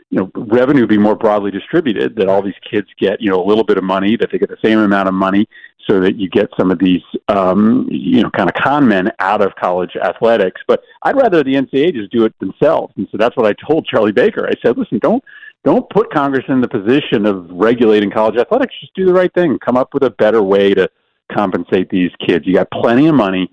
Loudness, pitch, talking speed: -14 LUFS, 120 Hz, 245 wpm